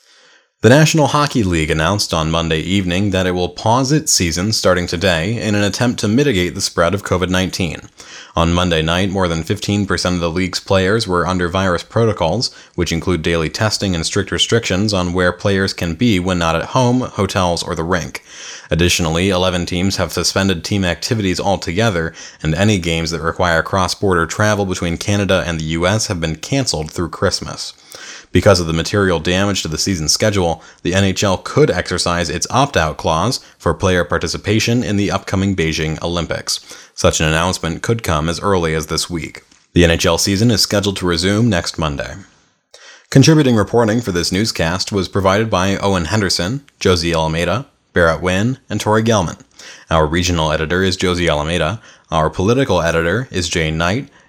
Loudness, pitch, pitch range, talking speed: -16 LUFS, 90 Hz, 85-100 Hz, 175 wpm